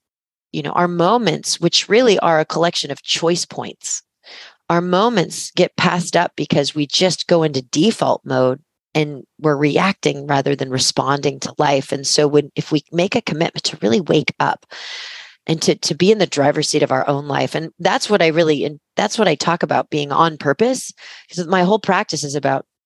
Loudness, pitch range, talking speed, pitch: -17 LUFS, 145-175 Hz, 200 wpm, 155 Hz